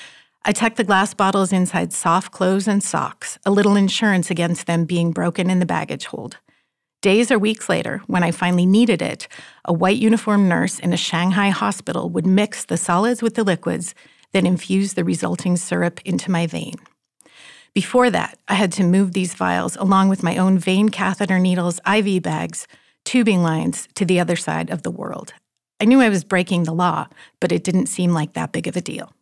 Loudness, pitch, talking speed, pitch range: -19 LUFS, 190 Hz, 195 wpm, 180-205 Hz